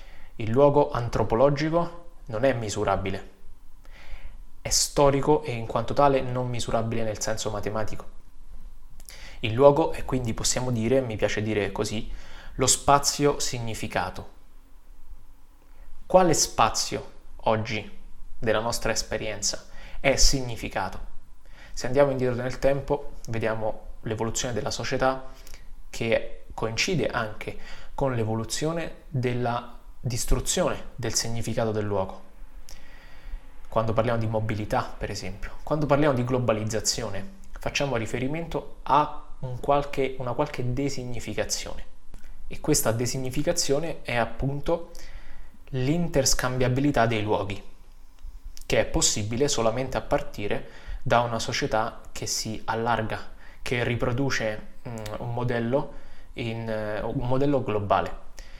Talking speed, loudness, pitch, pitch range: 105 wpm, -26 LUFS, 115 Hz, 105-135 Hz